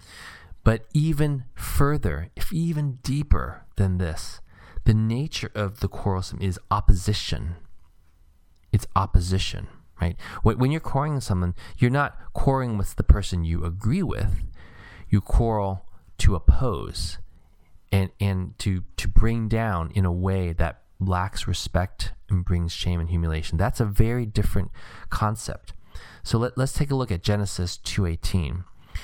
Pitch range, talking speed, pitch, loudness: 85-110 Hz, 140 wpm, 95 Hz, -26 LUFS